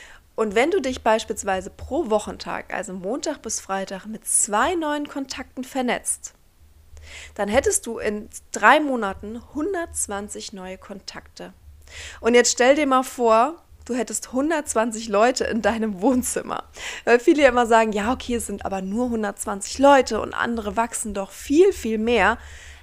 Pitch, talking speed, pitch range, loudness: 225 Hz, 150 wpm, 195-255 Hz, -22 LUFS